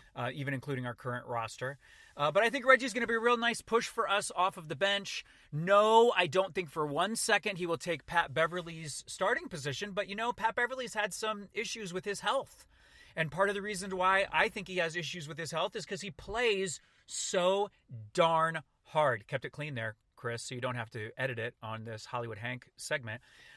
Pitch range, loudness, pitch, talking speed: 135-205 Hz, -32 LUFS, 175 Hz, 220 wpm